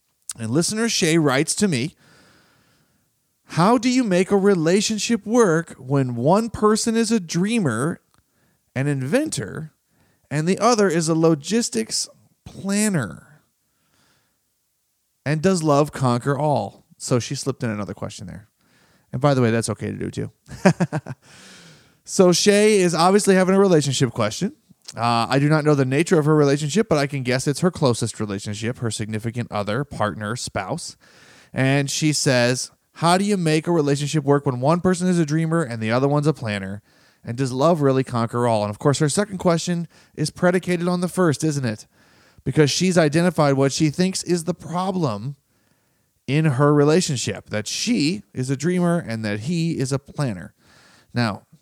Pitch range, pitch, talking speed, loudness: 125-180 Hz, 150 Hz, 170 wpm, -20 LUFS